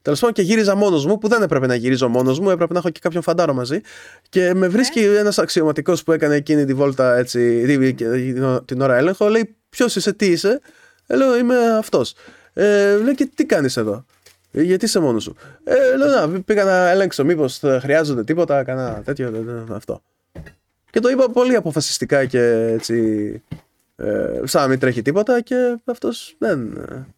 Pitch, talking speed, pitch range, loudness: 170 Hz, 185 wpm, 130-210 Hz, -17 LUFS